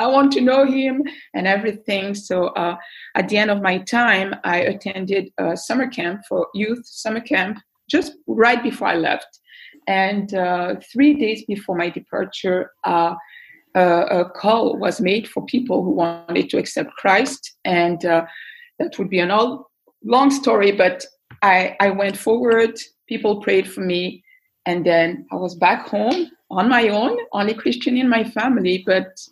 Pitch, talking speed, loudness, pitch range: 210 Hz, 170 wpm, -19 LUFS, 185-255 Hz